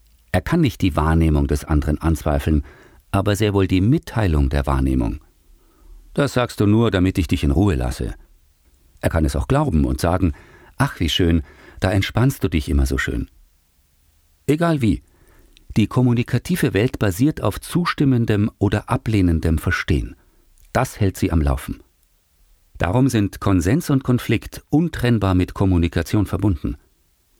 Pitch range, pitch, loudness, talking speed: 75-115 Hz, 95 Hz, -20 LUFS, 145 wpm